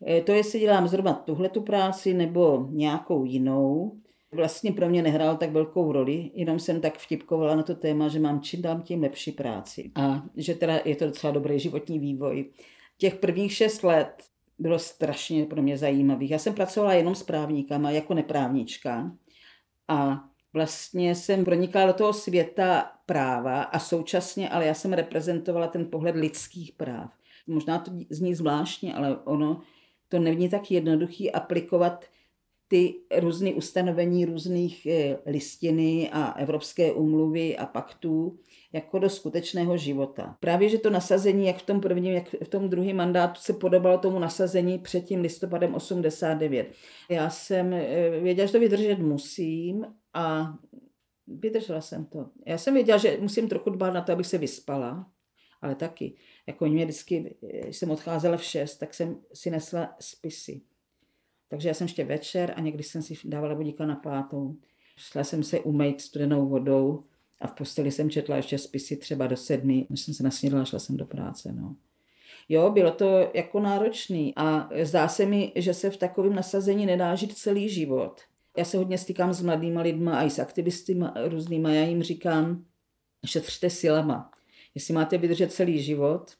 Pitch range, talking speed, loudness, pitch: 150-180 Hz, 165 wpm, -27 LUFS, 165 Hz